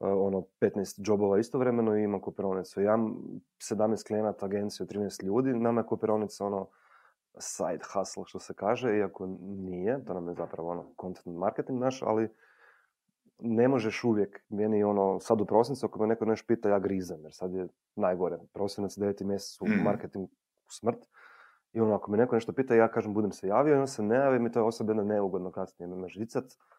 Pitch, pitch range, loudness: 105 Hz, 95-115 Hz, -30 LUFS